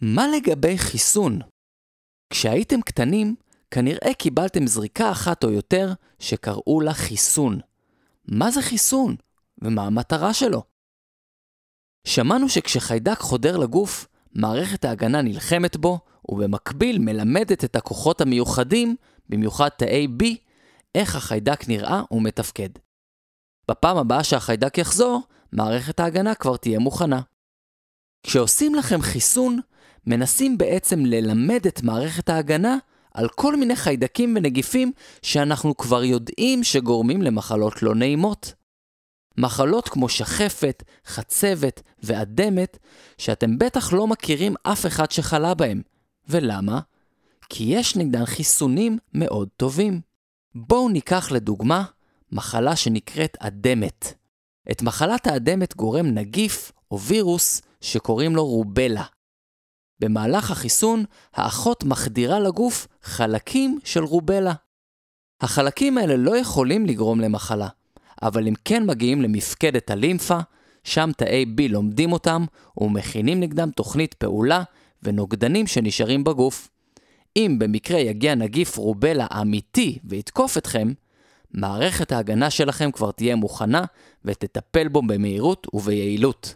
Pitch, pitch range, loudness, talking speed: 145 Hz, 115-185 Hz, -21 LUFS, 110 wpm